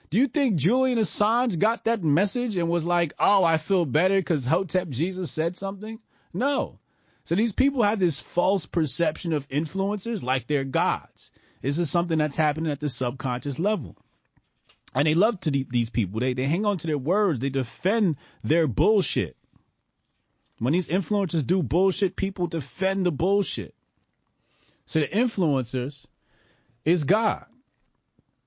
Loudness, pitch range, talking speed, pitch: -25 LUFS, 140-195 Hz, 155 wpm, 165 Hz